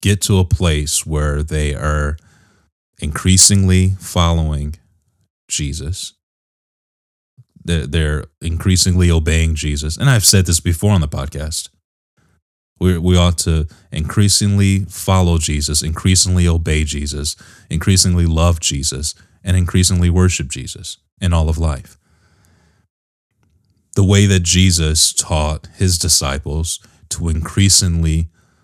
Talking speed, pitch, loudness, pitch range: 105 wpm, 85 Hz, -15 LUFS, 75-95 Hz